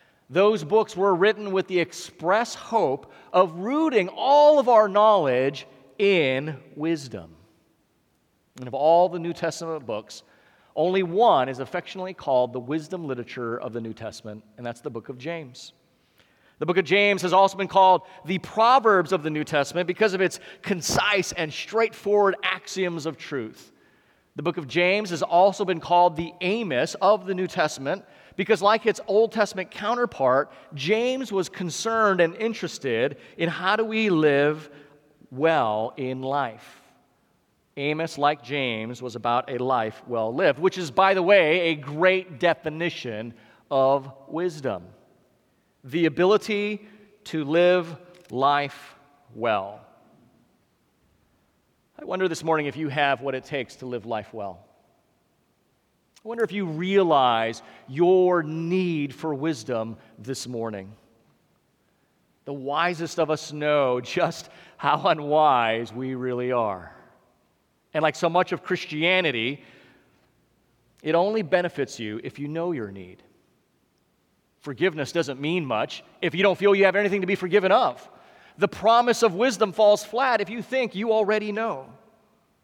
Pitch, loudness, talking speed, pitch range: 165 Hz, -23 LUFS, 145 wpm, 135-190 Hz